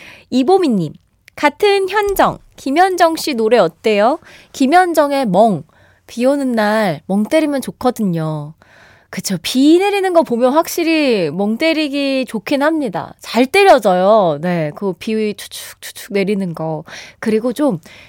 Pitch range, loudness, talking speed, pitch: 200-310 Hz, -15 LUFS, 250 characters per minute, 245 Hz